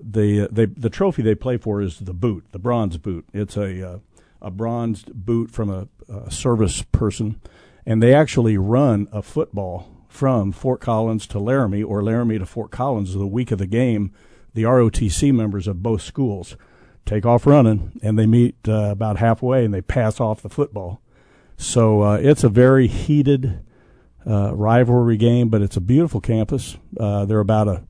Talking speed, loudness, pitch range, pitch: 180 wpm, -19 LUFS, 100-120 Hz, 110 Hz